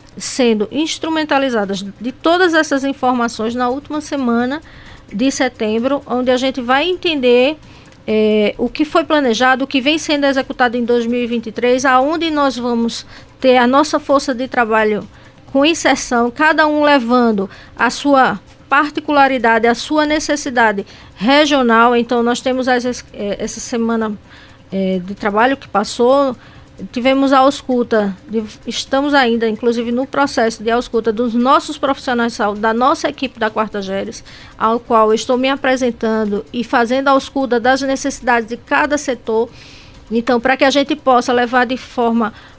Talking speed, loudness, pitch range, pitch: 145 wpm, -15 LUFS, 230-275 Hz, 250 Hz